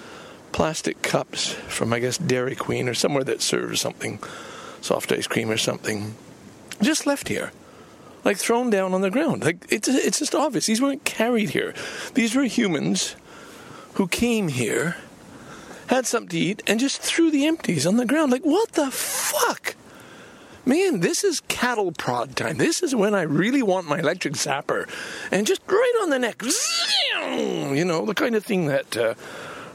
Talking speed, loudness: 175 wpm, -23 LUFS